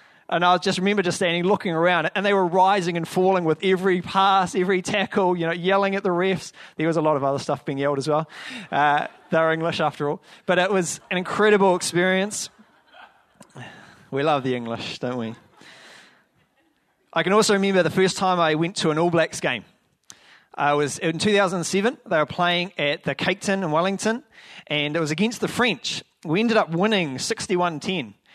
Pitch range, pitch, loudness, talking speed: 155-195 Hz, 180 Hz, -22 LUFS, 195 wpm